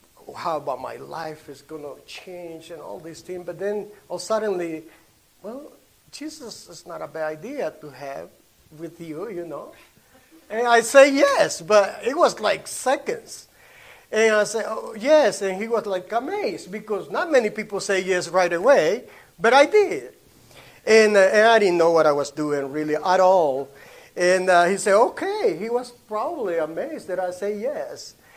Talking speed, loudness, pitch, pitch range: 180 wpm, -21 LUFS, 195 Hz, 165-230 Hz